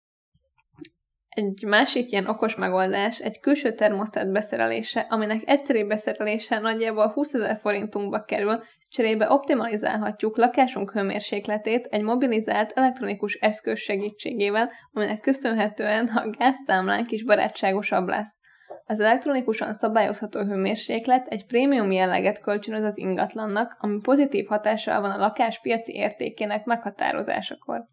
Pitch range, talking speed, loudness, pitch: 210-235 Hz, 110 wpm, -24 LUFS, 215 Hz